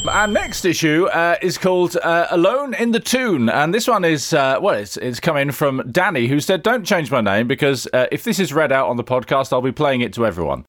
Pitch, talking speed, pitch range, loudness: 150 Hz, 245 wpm, 130-185 Hz, -17 LUFS